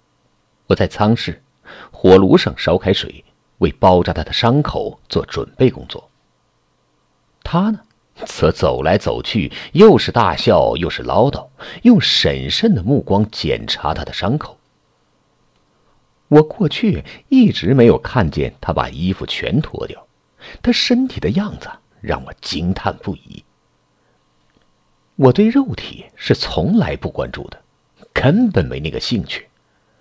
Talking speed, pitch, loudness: 190 characters per minute, 115 Hz, -16 LUFS